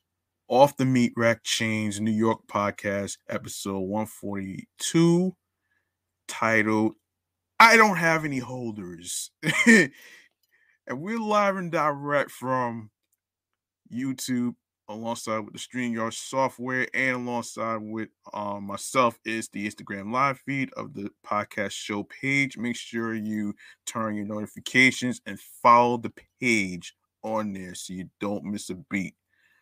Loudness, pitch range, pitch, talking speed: -25 LUFS, 100-130 Hz, 110 Hz, 125 wpm